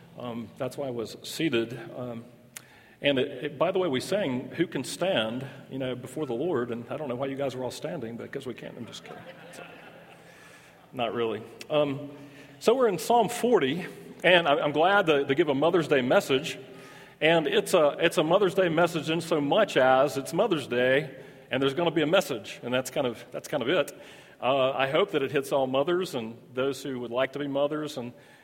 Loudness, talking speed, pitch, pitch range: -27 LUFS, 225 wpm, 135 Hz, 125-155 Hz